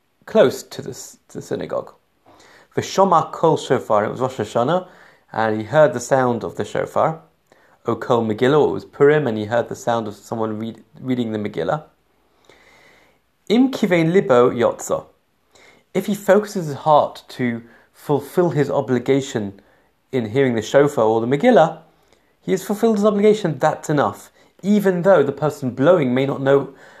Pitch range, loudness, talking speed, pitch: 120-180 Hz, -19 LUFS, 160 wpm, 140 Hz